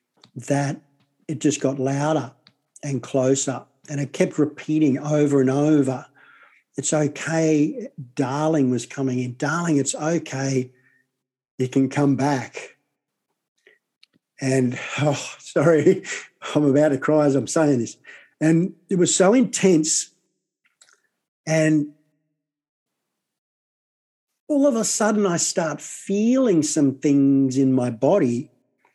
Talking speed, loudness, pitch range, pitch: 120 wpm, -21 LUFS, 135-155 Hz, 145 Hz